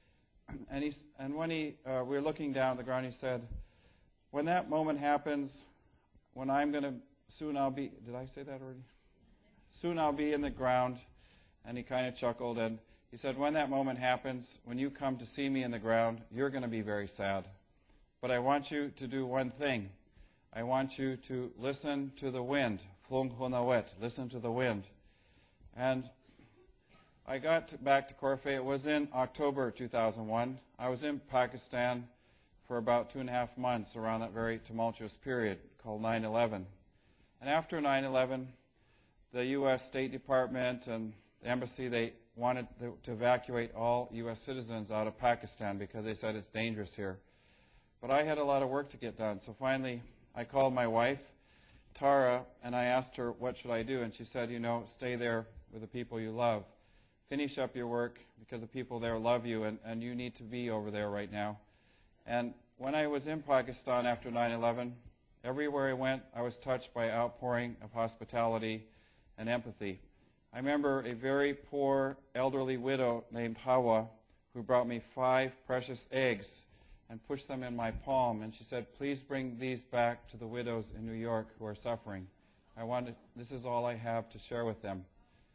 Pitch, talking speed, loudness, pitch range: 120 Hz, 185 wpm, -36 LUFS, 115-130 Hz